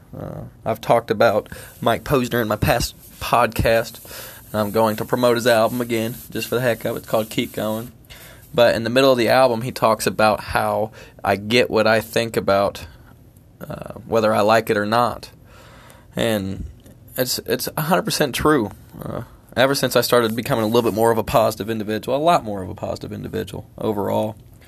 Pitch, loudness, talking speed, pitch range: 115 Hz, -20 LUFS, 195 wpm, 110-120 Hz